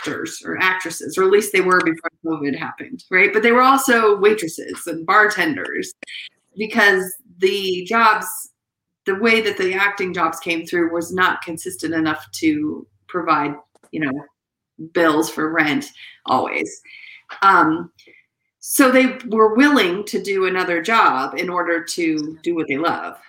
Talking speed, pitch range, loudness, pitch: 145 wpm, 165-225 Hz, -18 LUFS, 190 Hz